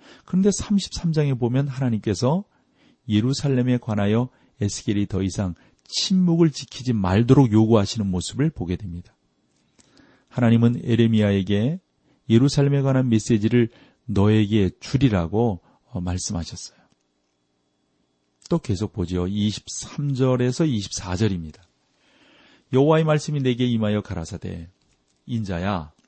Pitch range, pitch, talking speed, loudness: 95-130 Hz, 110 Hz, 260 characters per minute, -22 LUFS